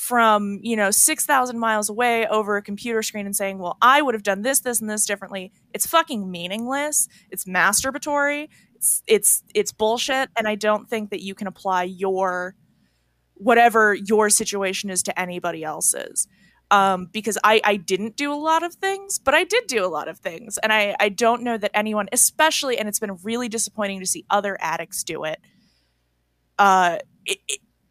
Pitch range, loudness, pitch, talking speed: 190-245 Hz, -21 LUFS, 210 Hz, 185 wpm